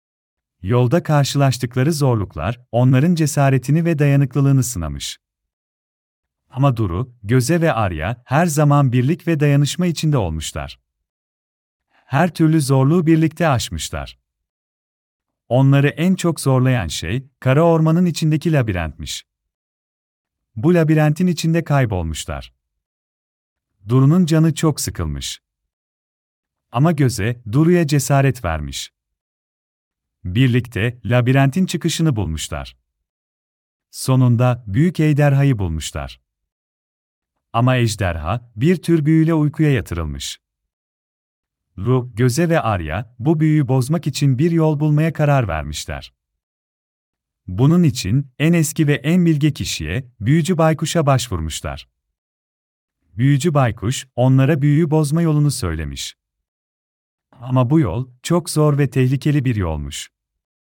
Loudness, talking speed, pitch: -17 LUFS, 100 wpm, 125 Hz